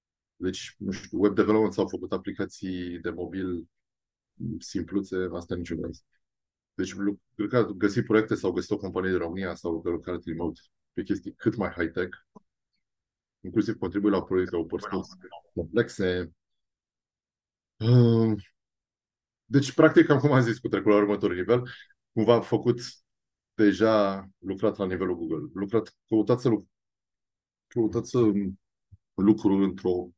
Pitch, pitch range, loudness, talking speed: 100 Hz, 90-110 Hz, -27 LUFS, 130 wpm